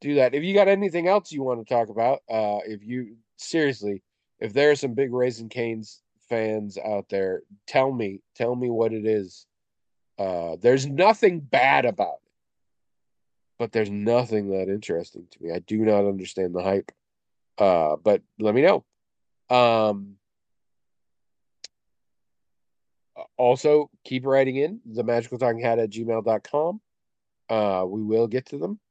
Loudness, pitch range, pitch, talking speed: -24 LUFS, 105-135 Hz, 115 Hz, 155 wpm